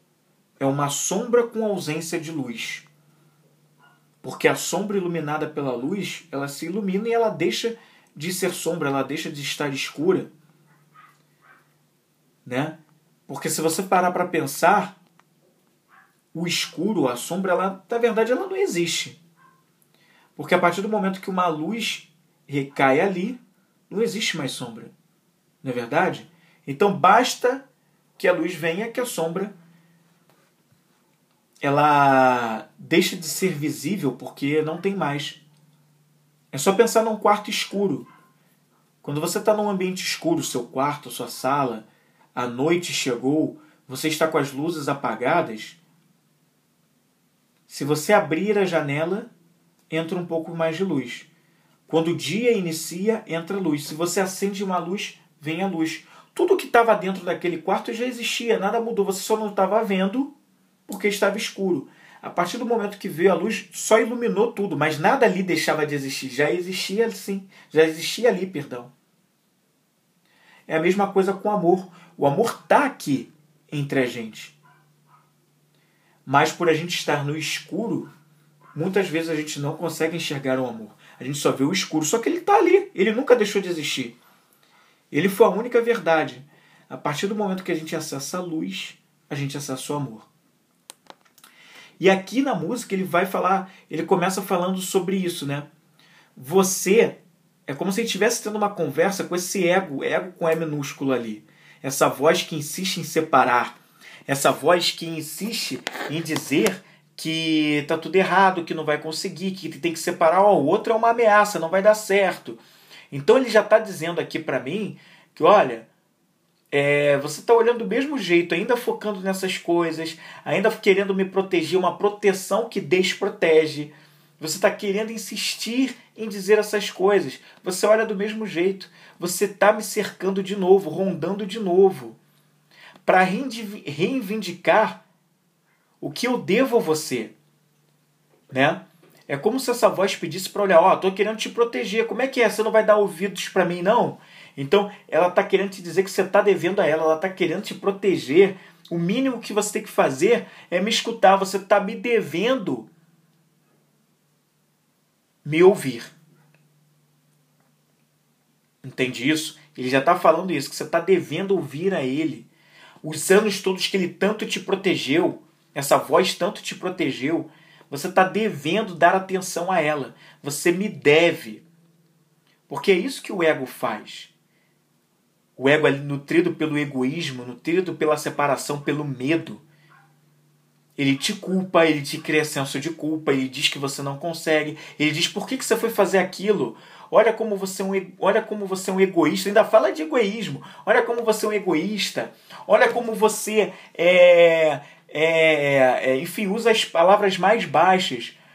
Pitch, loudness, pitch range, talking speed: 175 Hz, -22 LUFS, 155-205 Hz, 160 wpm